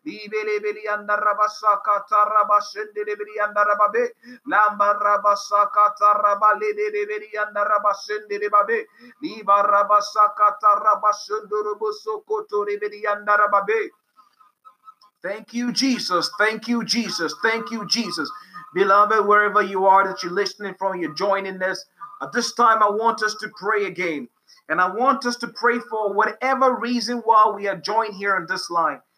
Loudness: -20 LUFS